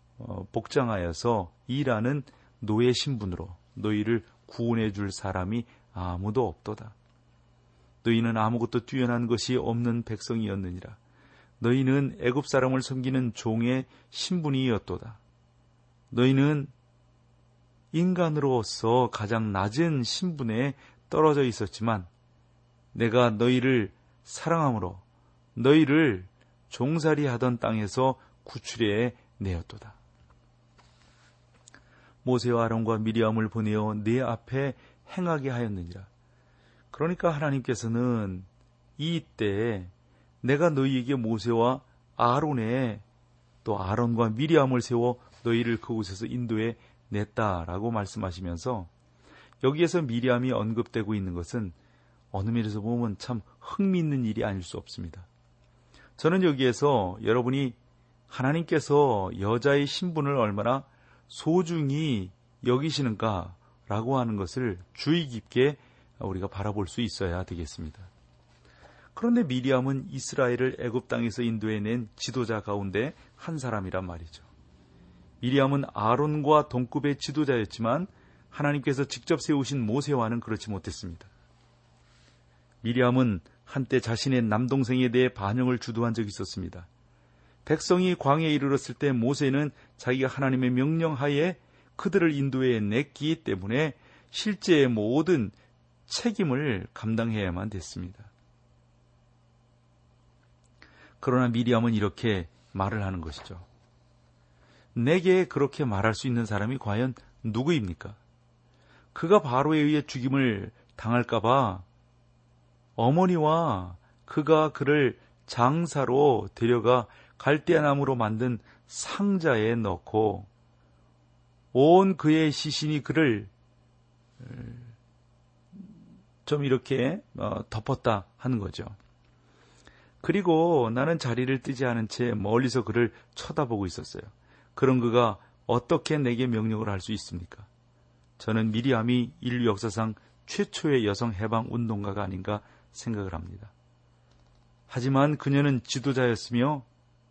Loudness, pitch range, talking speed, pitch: -27 LUFS, 105-135 Hz, 255 characters per minute, 120 Hz